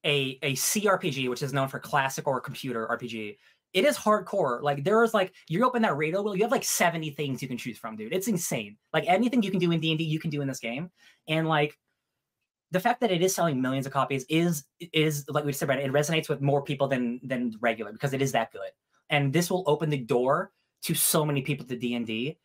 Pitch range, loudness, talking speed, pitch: 135-175 Hz, -27 LUFS, 250 wpm, 150 Hz